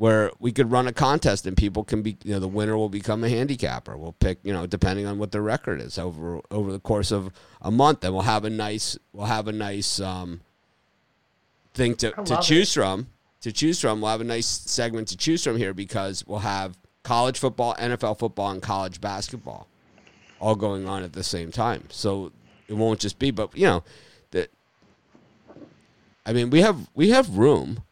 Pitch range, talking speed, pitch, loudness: 95-115 Hz, 210 wpm, 105 Hz, -24 LUFS